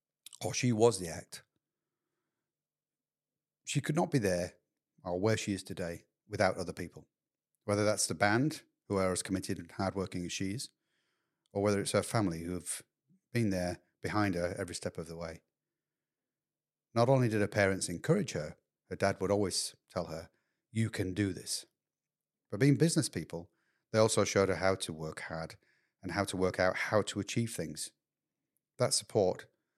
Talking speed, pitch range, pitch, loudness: 175 wpm, 90-115 Hz, 100 Hz, -33 LUFS